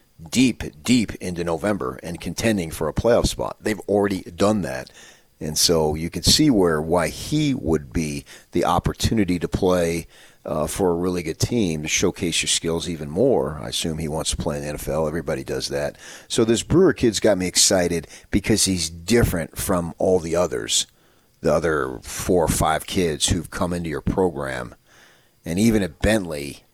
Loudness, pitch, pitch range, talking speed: -21 LUFS, 90 Hz, 80-105 Hz, 180 wpm